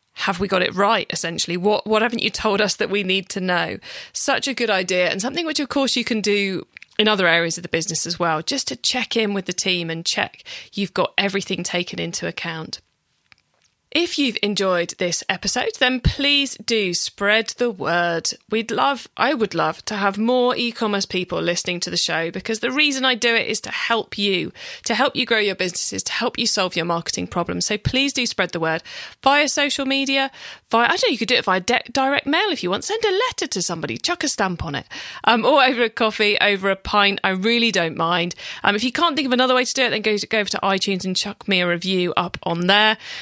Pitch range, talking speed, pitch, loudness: 180-245 Hz, 240 wpm, 205 Hz, -20 LUFS